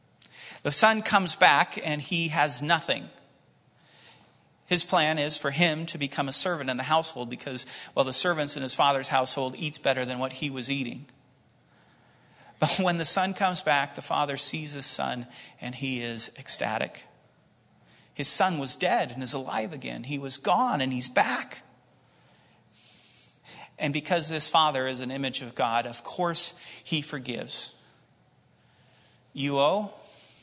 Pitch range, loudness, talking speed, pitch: 130-165 Hz, -25 LUFS, 155 wpm, 145 Hz